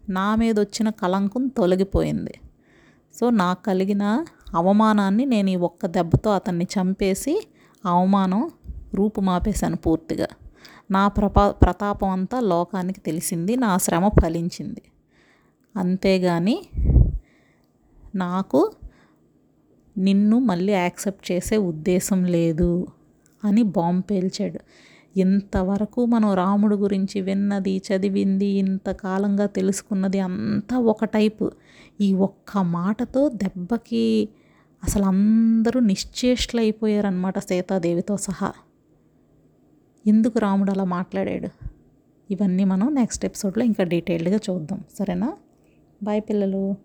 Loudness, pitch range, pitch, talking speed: -22 LUFS, 190-215 Hz, 195 Hz, 90 wpm